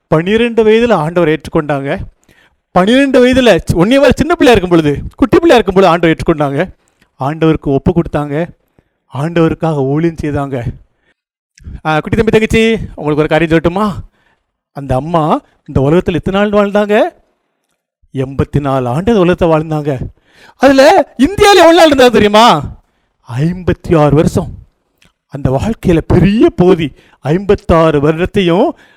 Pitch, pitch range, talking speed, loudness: 170 Hz, 150-215 Hz, 120 wpm, -10 LUFS